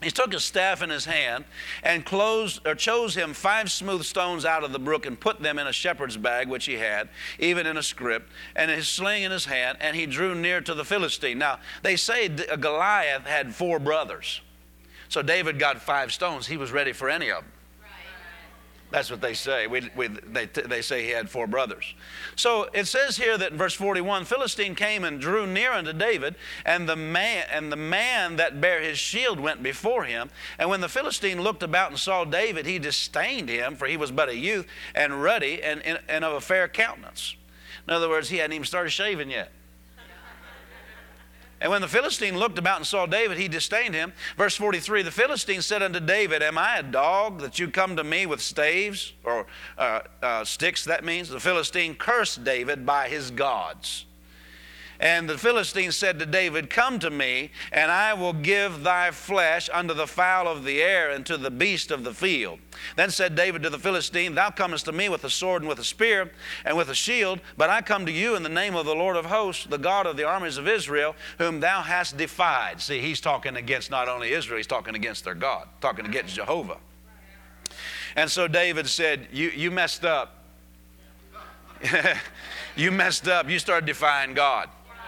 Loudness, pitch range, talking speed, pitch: -25 LUFS, 145-190 Hz, 205 wpm, 170 Hz